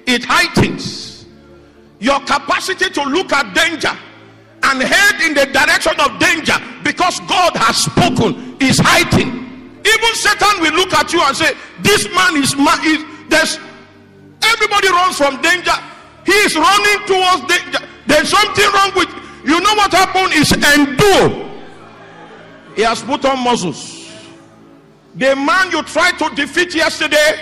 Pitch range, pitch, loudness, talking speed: 280-370 Hz, 320 Hz, -12 LUFS, 145 wpm